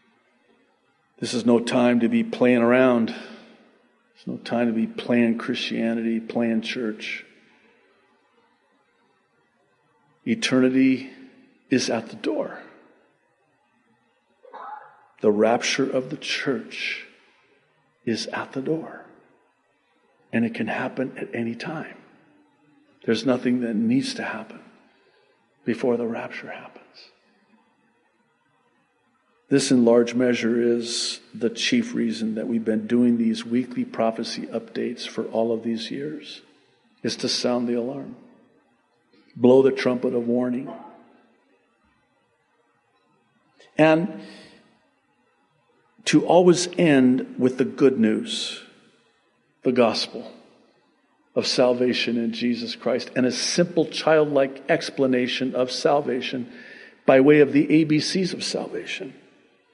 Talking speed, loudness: 110 wpm, -22 LUFS